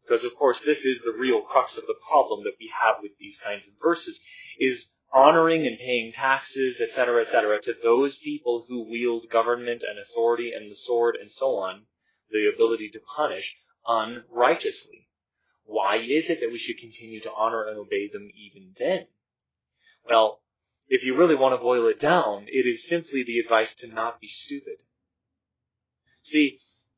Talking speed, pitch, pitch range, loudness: 175 wpm, 125 Hz, 115-170 Hz, -24 LUFS